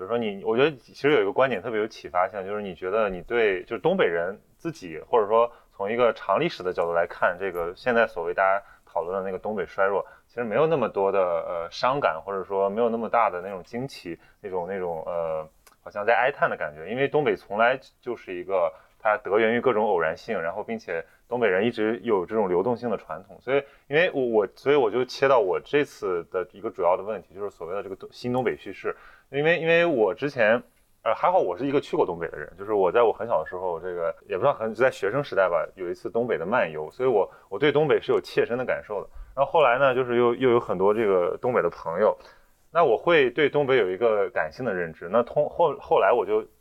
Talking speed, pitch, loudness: 360 characters per minute, 370 Hz, -25 LUFS